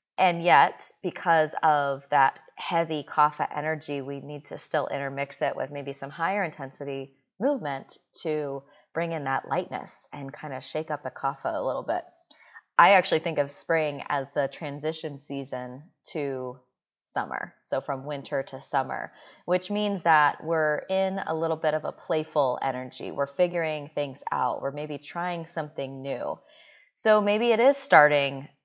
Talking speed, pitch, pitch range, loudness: 160 wpm, 150 Hz, 140-170 Hz, -27 LUFS